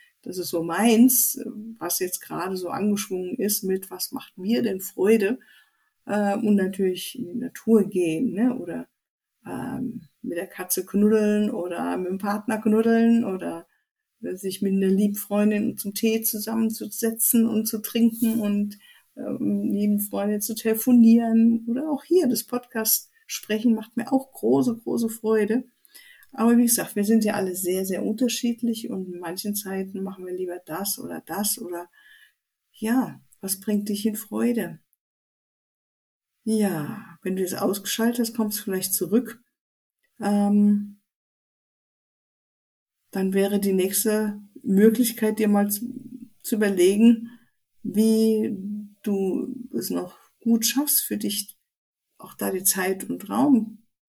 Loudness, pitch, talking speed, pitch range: -23 LUFS, 215 Hz, 135 wpm, 195-235 Hz